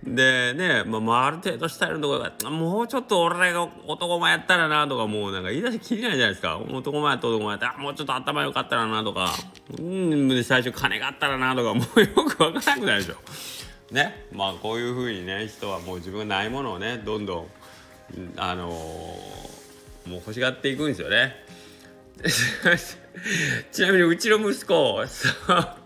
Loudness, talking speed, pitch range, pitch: -24 LUFS, 370 characters per minute, 100-160 Hz, 125 Hz